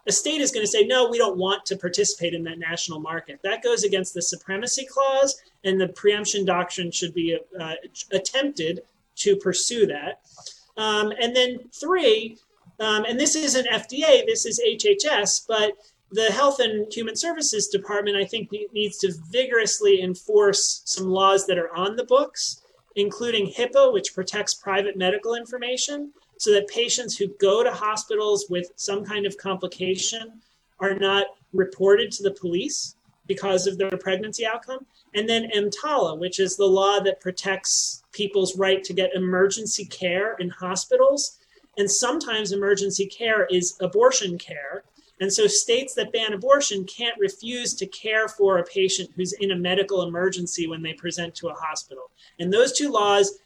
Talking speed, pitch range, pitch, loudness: 165 wpm, 185-235 Hz, 200 Hz, -23 LUFS